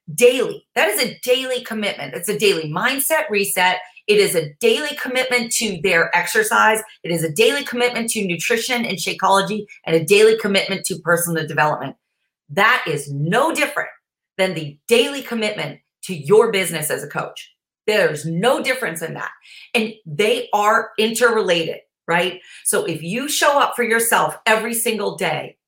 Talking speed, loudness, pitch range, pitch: 160 wpm, -18 LUFS, 175-240 Hz, 215 Hz